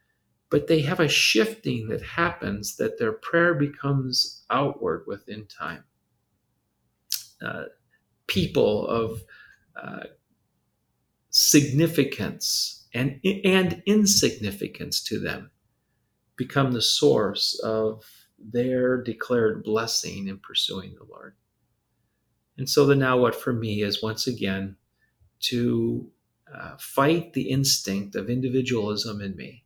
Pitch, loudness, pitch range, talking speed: 125 Hz, -24 LUFS, 110-140 Hz, 110 wpm